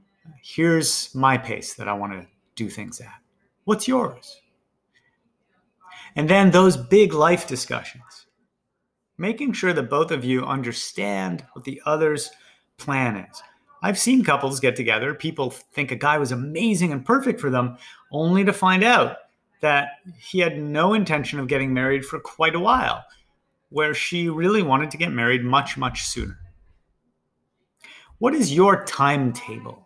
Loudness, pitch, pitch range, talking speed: -21 LUFS, 150 Hz, 130-185 Hz, 150 wpm